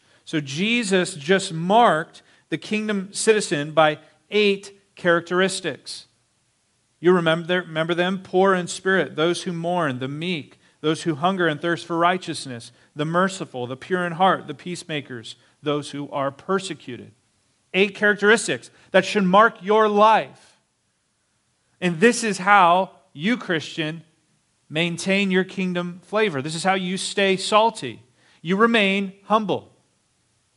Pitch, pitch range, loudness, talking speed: 175 Hz, 155-195 Hz, -21 LUFS, 130 wpm